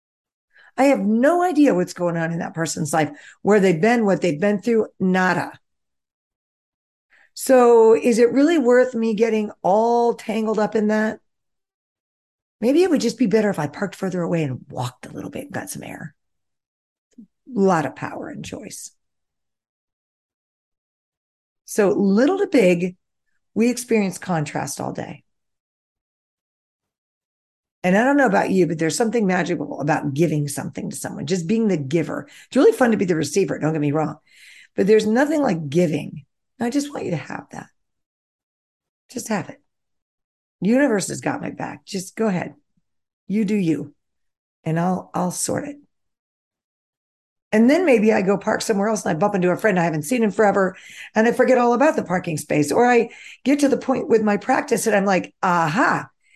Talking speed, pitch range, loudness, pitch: 180 wpm, 170-235 Hz, -20 LUFS, 205 Hz